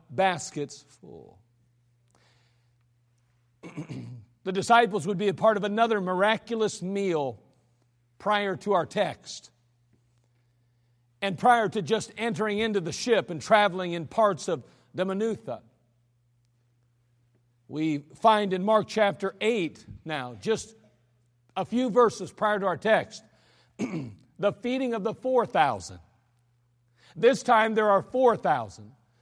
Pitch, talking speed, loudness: 155 Hz, 115 wpm, -26 LUFS